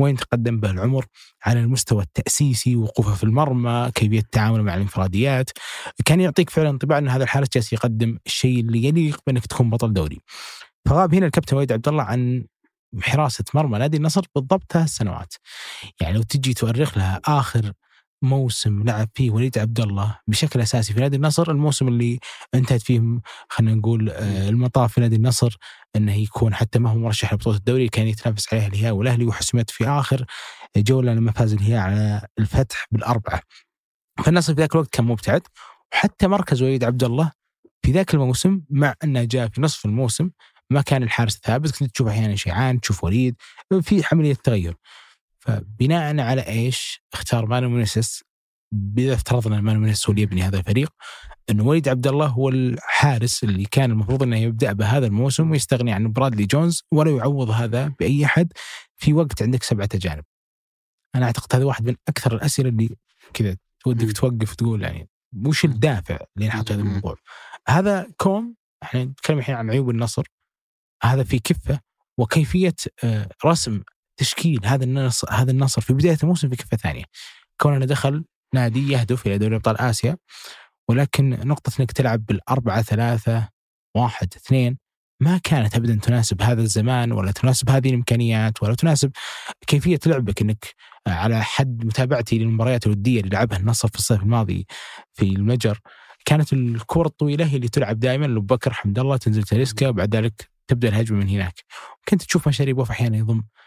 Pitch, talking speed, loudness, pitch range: 120 Hz, 160 wpm, -21 LUFS, 110-140 Hz